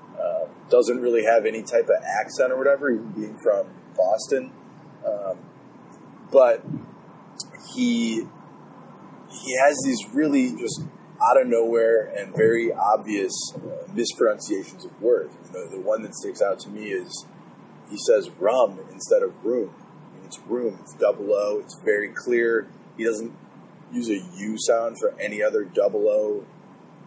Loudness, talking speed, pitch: -23 LUFS, 155 wpm, 200 Hz